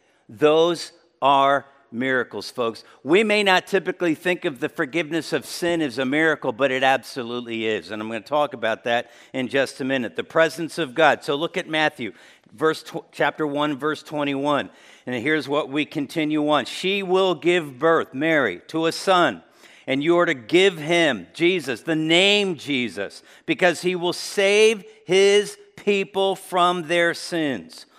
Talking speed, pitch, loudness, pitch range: 165 wpm, 160 Hz, -21 LUFS, 140-175 Hz